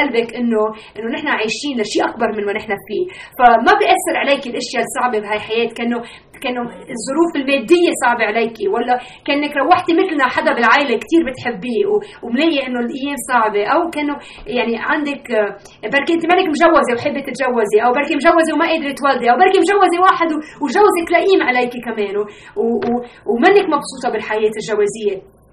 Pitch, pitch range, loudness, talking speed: 255 Hz, 230-325 Hz, -16 LUFS, 150 wpm